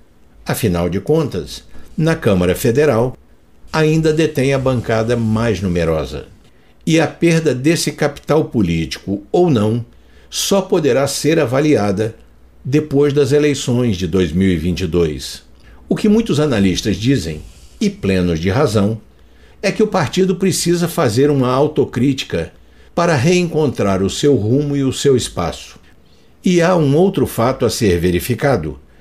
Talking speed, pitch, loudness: 130 wpm, 120 Hz, -16 LUFS